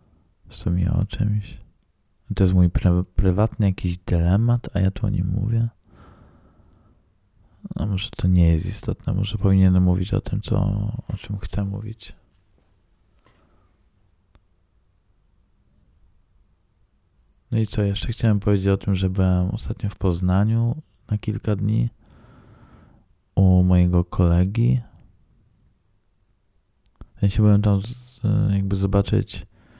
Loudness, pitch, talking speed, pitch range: -22 LUFS, 100 Hz, 125 wpm, 90-105 Hz